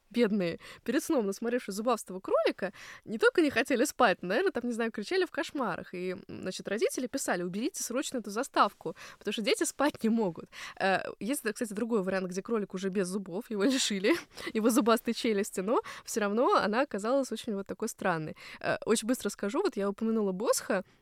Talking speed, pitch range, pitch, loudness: 180 wpm, 200-260 Hz, 225 Hz, -31 LUFS